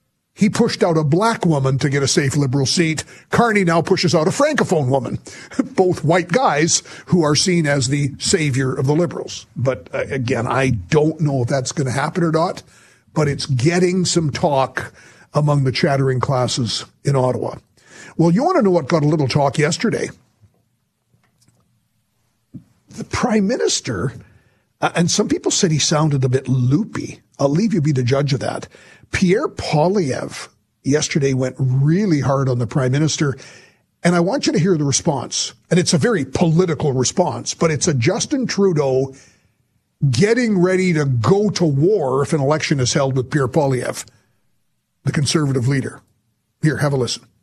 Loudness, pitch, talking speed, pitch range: -18 LUFS, 150 Hz, 170 wpm, 135-175 Hz